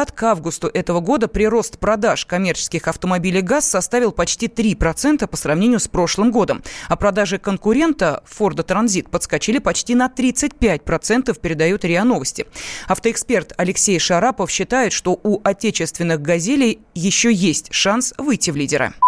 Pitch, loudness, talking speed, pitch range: 200 Hz, -18 LUFS, 140 wpm, 175-235 Hz